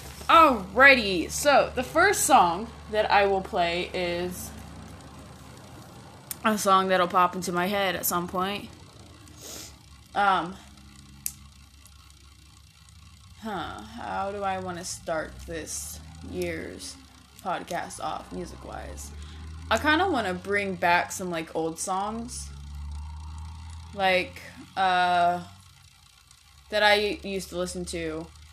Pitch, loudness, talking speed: 165 Hz, -25 LUFS, 110 wpm